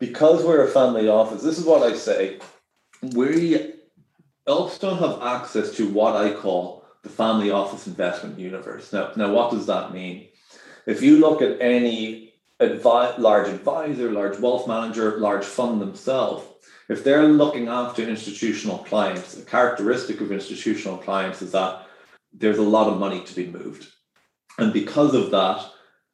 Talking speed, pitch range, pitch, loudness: 160 wpm, 100-145 Hz, 115 Hz, -21 LUFS